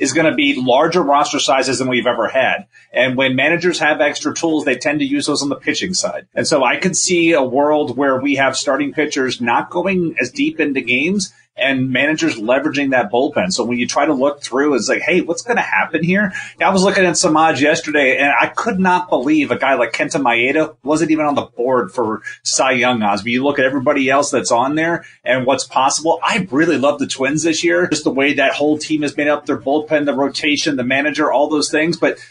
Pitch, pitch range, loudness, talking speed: 150 Hz, 140-180 Hz, -15 LUFS, 235 wpm